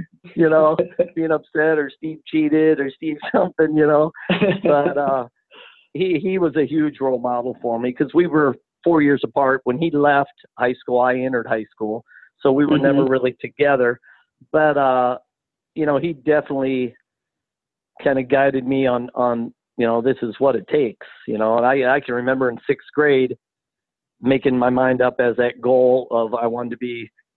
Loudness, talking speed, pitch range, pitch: -19 LUFS, 185 wpm, 125-155 Hz, 135 Hz